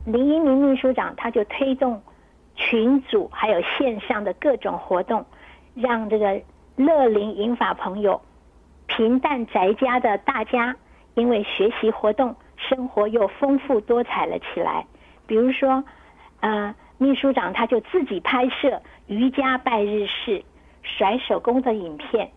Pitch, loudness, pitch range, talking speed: 240 Hz, -22 LUFS, 215-265 Hz, 205 characters per minute